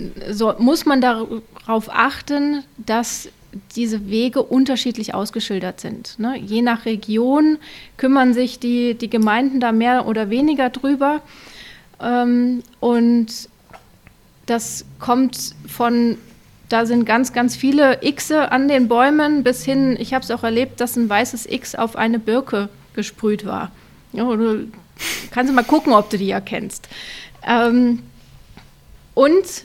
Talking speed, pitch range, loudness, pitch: 140 wpm, 225-260 Hz, -18 LUFS, 240 Hz